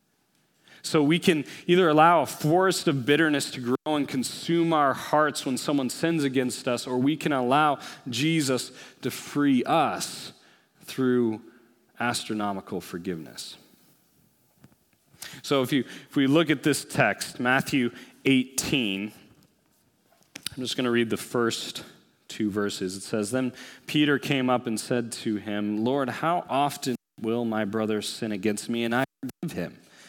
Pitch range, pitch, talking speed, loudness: 115-150 Hz, 130 Hz, 150 wpm, -26 LUFS